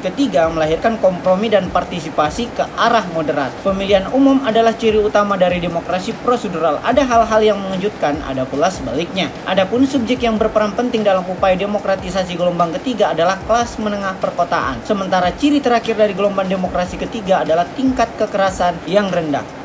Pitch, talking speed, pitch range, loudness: 200 Hz, 150 wpm, 180-230 Hz, -16 LUFS